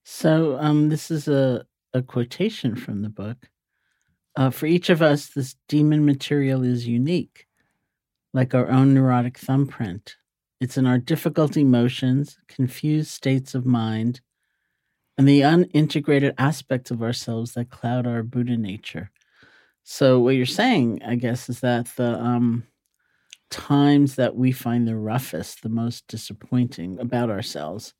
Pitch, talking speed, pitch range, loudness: 125 Hz, 140 wpm, 120-140 Hz, -22 LUFS